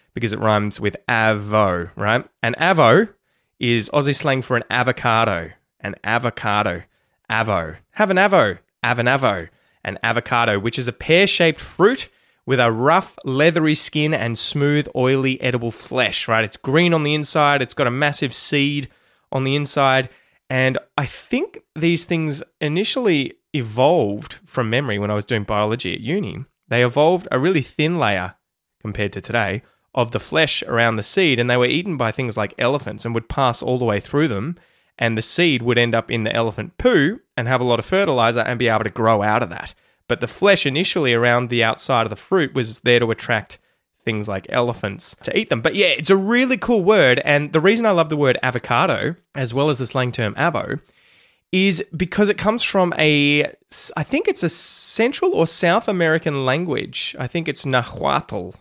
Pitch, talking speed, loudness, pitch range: 130 Hz, 190 wpm, -19 LUFS, 115-160 Hz